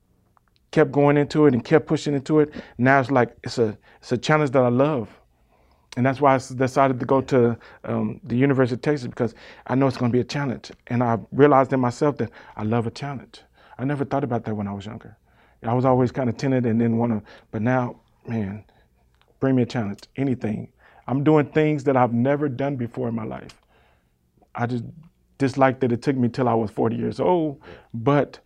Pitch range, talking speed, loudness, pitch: 115-140 Hz, 220 wpm, -22 LUFS, 125 Hz